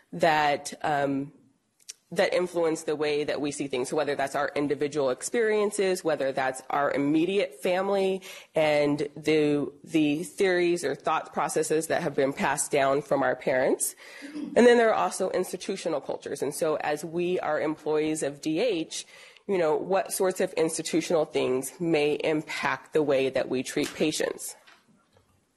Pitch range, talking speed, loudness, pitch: 145-190 Hz, 155 wpm, -27 LUFS, 160 Hz